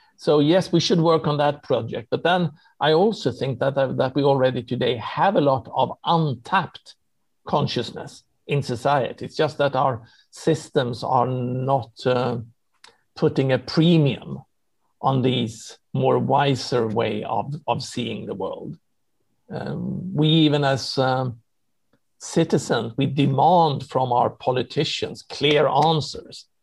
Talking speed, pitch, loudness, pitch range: 135 wpm, 135 Hz, -22 LUFS, 125-155 Hz